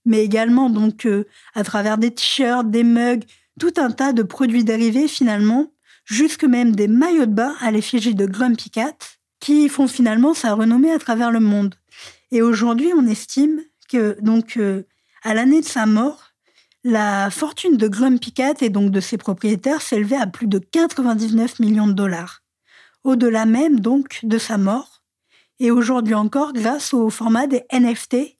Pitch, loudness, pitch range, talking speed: 235 Hz, -18 LUFS, 220-265 Hz, 170 wpm